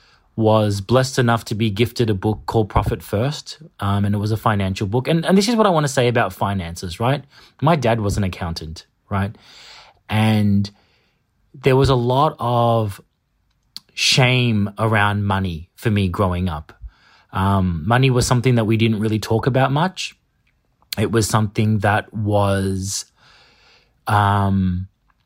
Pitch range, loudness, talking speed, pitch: 100-125 Hz, -19 LUFS, 155 wpm, 110 Hz